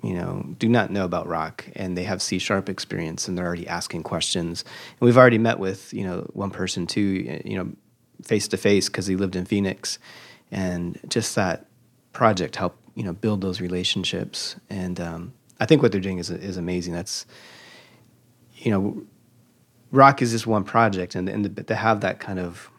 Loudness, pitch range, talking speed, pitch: -23 LUFS, 90-115 Hz, 190 wpm, 95 Hz